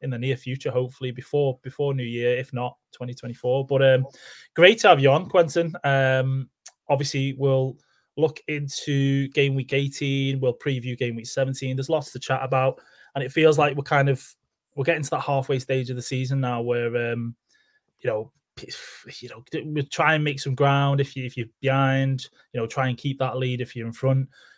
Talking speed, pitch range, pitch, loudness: 205 wpm, 125-145 Hz, 135 Hz, -24 LUFS